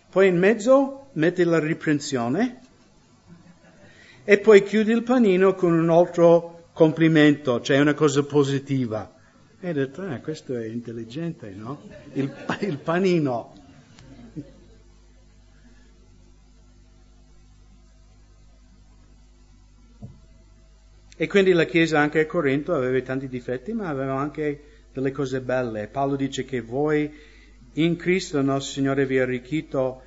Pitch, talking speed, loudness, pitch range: 145 Hz, 115 wpm, -22 LUFS, 130-170 Hz